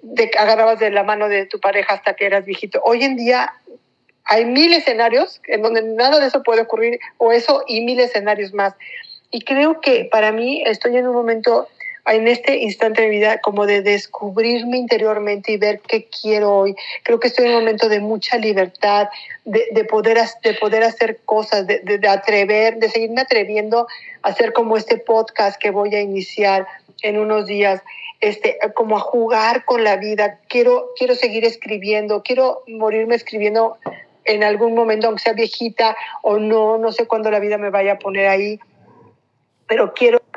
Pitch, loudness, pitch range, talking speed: 225 Hz, -16 LUFS, 210-235 Hz, 185 wpm